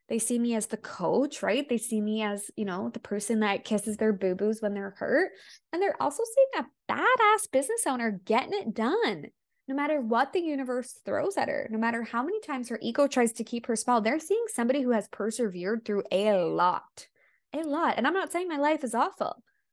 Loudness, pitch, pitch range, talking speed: -28 LUFS, 240 Hz, 220-300 Hz, 220 wpm